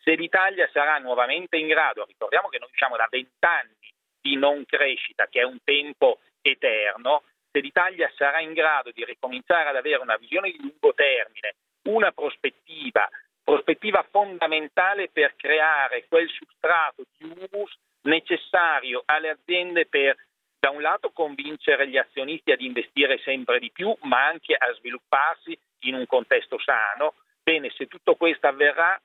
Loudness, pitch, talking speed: -23 LUFS, 180 Hz, 150 wpm